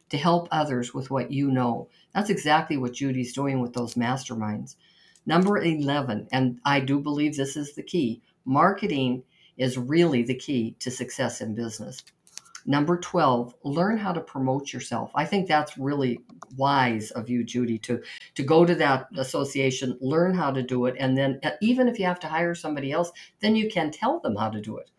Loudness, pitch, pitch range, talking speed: -26 LUFS, 135 Hz, 125-160 Hz, 190 wpm